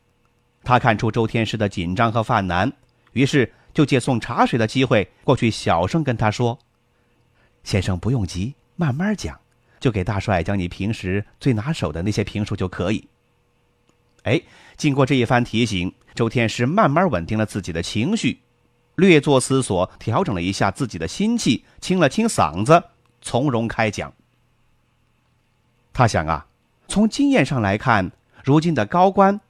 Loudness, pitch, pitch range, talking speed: -20 LUFS, 120 Hz, 105-135 Hz, 230 characters per minute